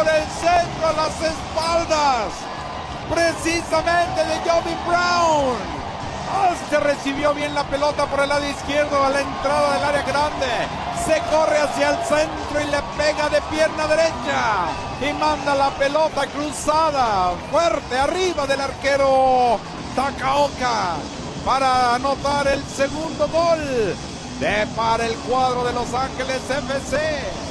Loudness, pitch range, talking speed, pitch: -20 LUFS, 275-315 Hz, 130 wpm, 295 Hz